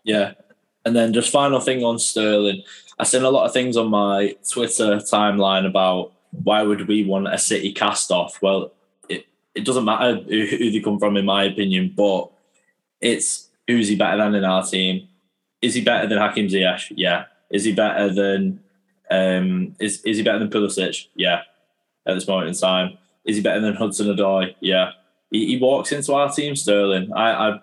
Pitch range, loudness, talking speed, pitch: 95-110 Hz, -20 LUFS, 190 wpm, 105 Hz